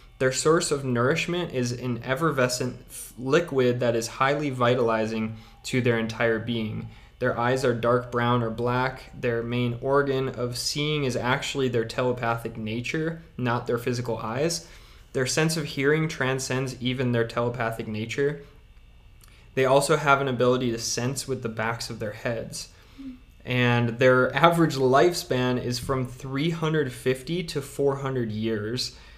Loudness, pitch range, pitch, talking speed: -25 LUFS, 115-135 Hz, 125 Hz, 140 wpm